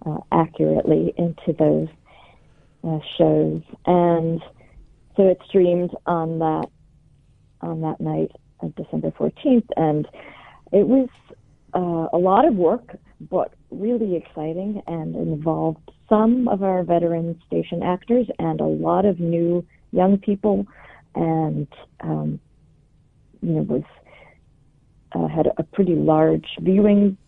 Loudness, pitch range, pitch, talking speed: -21 LUFS, 150-190 Hz, 165 Hz, 115 wpm